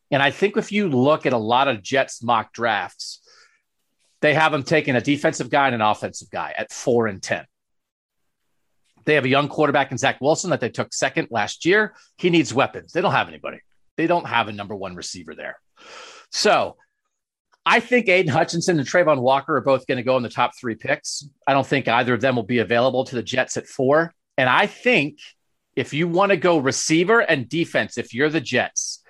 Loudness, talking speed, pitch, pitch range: -20 LUFS, 215 wpm, 140 Hz, 125-165 Hz